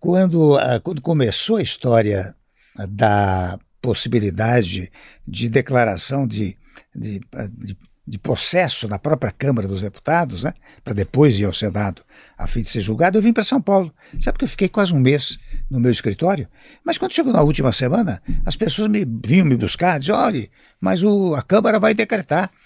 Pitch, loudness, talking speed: 135 Hz, -19 LUFS, 175 wpm